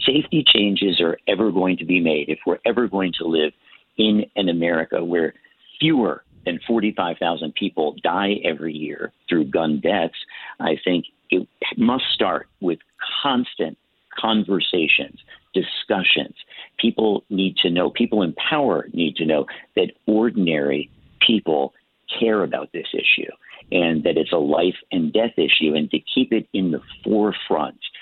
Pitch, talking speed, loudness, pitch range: 95 Hz, 150 wpm, -20 LUFS, 80-110 Hz